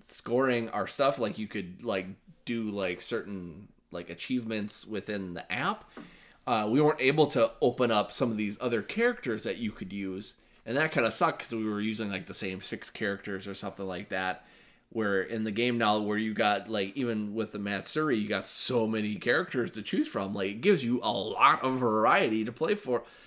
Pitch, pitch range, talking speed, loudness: 110 Hz, 100-120 Hz, 210 wpm, -30 LUFS